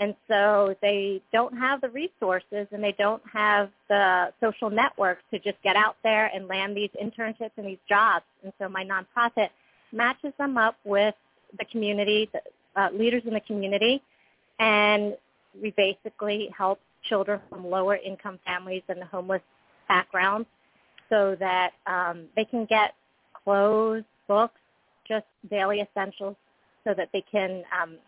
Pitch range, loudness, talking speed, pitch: 195-220 Hz, -26 LUFS, 150 wpm, 205 Hz